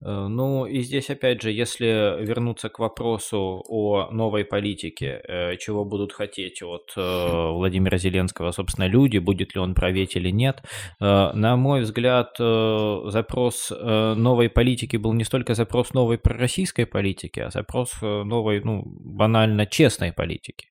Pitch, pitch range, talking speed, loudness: 110 Hz, 95-120 Hz, 135 wpm, -23 LUFS